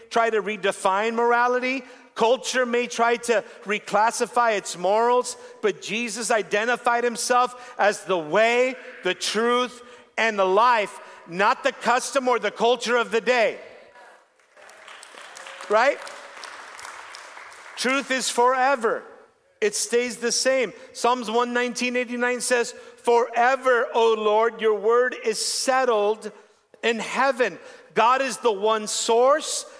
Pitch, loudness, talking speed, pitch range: 240 Hz, -22 LUFS, 115 wpm, 225-255 Hz